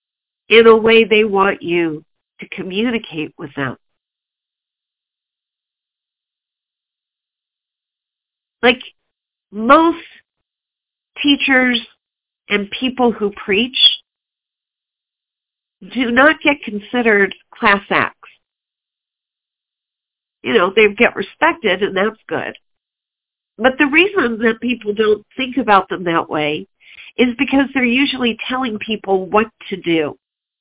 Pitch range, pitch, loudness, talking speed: 195-255 Hz, 220 Hz, -15 LUFS, 100 wpm